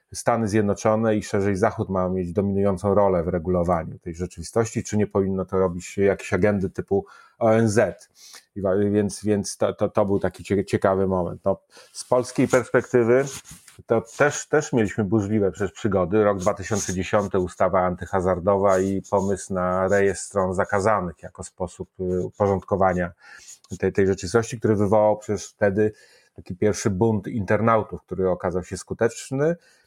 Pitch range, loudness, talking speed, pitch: 95-110 Hz, -23 LUFS, 140 wpm, 100 Hz